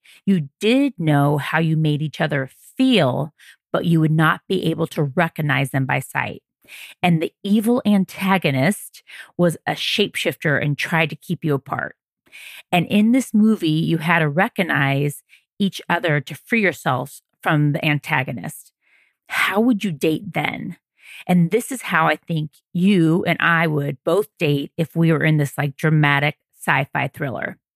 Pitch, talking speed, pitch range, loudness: 165 Hz, 165 wpm, 150-190 Hz, -20 LUFS